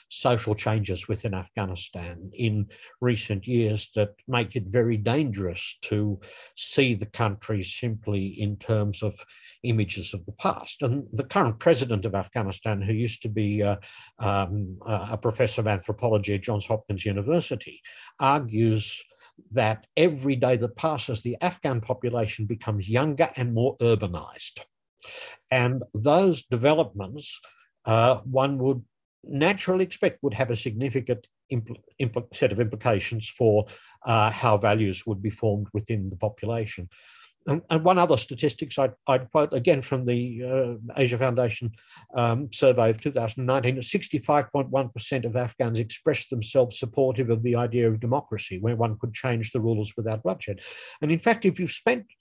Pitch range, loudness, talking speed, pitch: 105-130 Hz, -26 LUFS, 150 wpm, 115 Hz